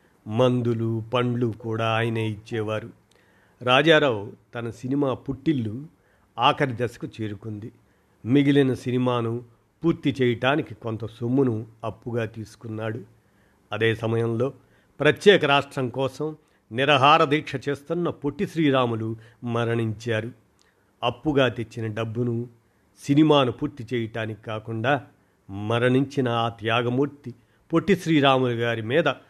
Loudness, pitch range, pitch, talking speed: -24 LUFS, 110-140 Hz, 120 Hz, 90 wpm